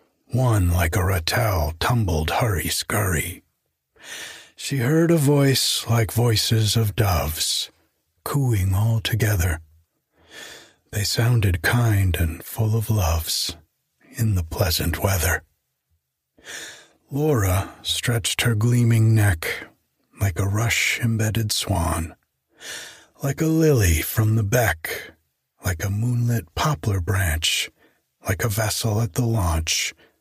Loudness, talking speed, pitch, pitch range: -21 LUFS, 110 wpm, 105 Hz, 85-115 Hz